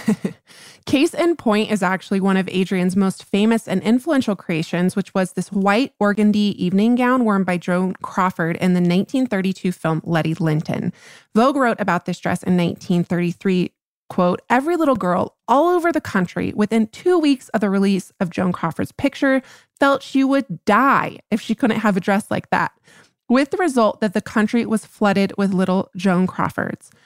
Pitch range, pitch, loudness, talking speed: 180-235 Hz, 200 Hz, -19 LUFS, 175 wpm